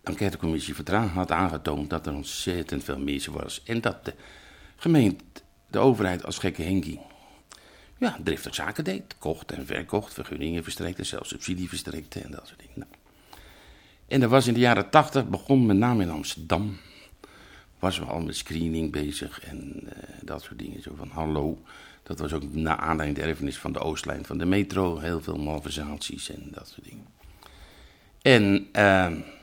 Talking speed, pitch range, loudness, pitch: 170 wpm, 80-100 Hz, -26 LUFS, 85 Hz